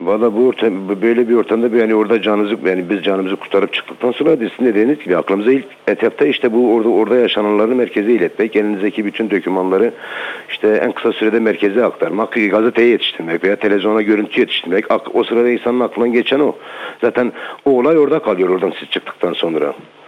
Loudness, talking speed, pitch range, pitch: -15 LUFS, 175 wpm, 105-120 Hz, 110 Hz